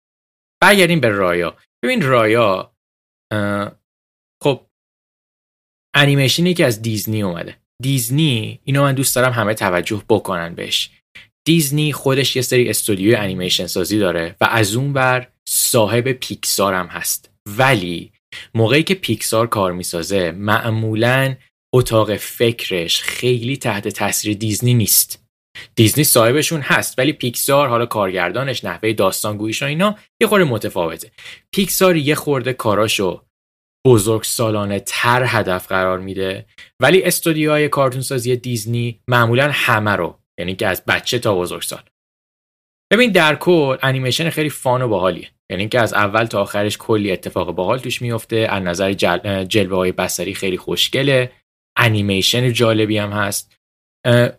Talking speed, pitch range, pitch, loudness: 130 wpm, 105-130 Hz, 115 Hz, -17 LUFS